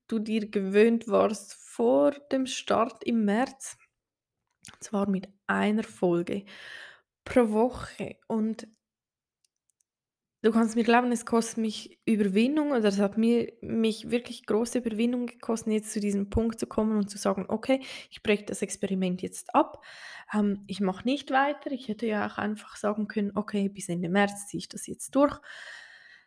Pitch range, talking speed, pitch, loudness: 205-240 Hz, 160 wpm, 220 Hz, -28 LUFS